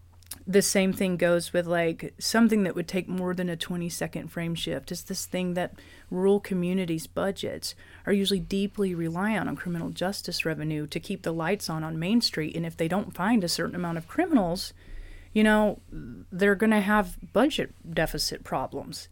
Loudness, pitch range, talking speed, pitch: -27 LUFS, 165-200 Hz, 185 wpm, 180 Hz